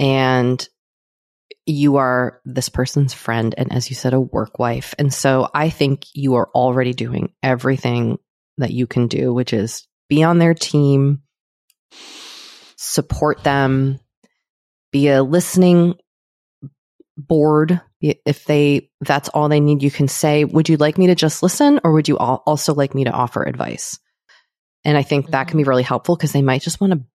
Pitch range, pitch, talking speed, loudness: 130-150 Hz, 140 Hz, 170 wpm, -17 LUFS